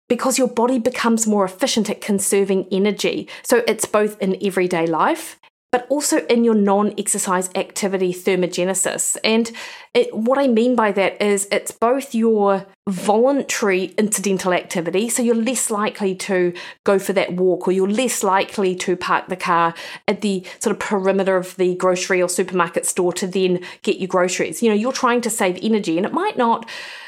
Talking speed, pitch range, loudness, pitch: 180 wpm, 185-230 Hz, -19 LUFS, 200 Hz